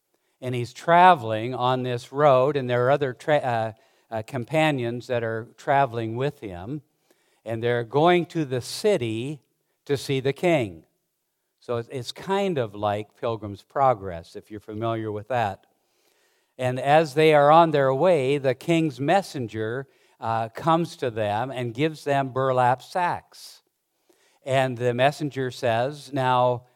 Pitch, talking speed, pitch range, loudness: 130 Hz, 145 wpm, 115-145 Hz, -23 LUFS